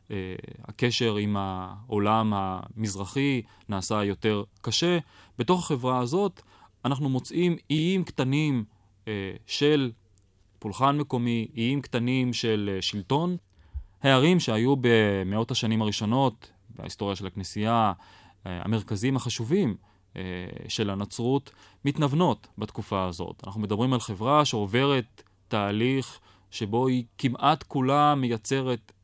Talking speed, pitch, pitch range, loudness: 95 wpm, 115 Hz, 100-135 Hz, -27 LUFS